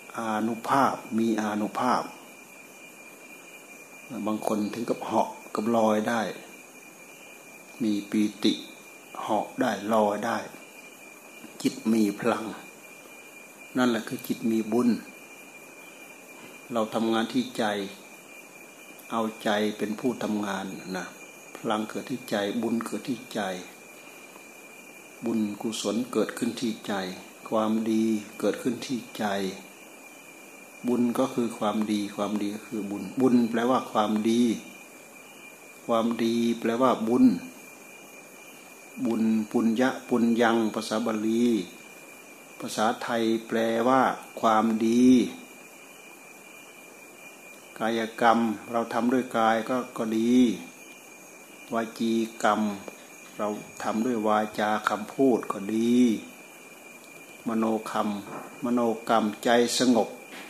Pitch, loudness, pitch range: 115 Hz, -27 LUFS, 105-115 Hz